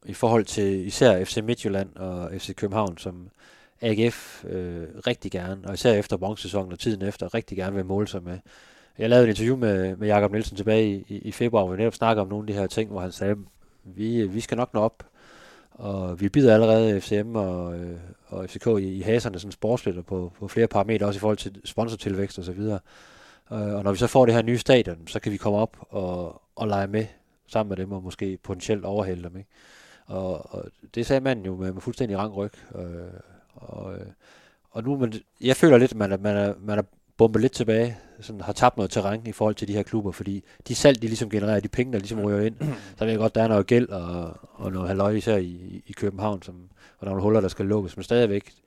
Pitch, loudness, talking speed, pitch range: 105 Hz, -25 LUFS, 230 wpm, 95-110 Hz